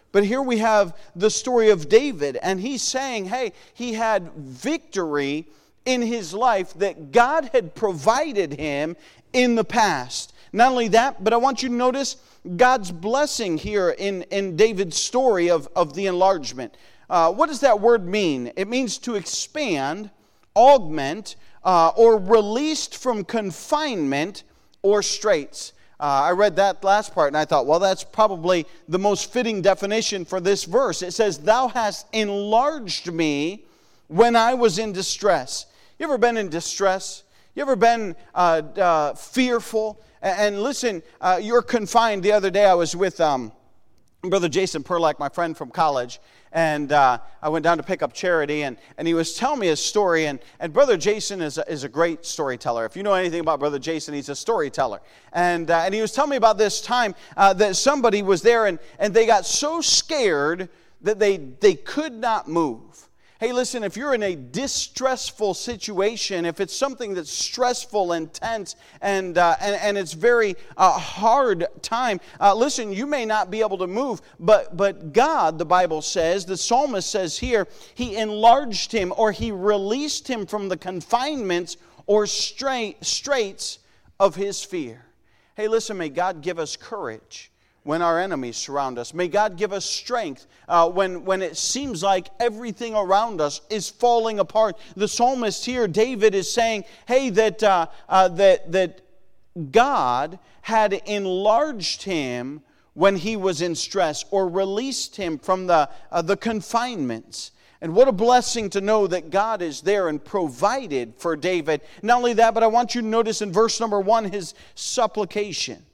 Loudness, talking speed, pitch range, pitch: -21 LUFS, 175 wpm, 175-230 Hz, 200 Hz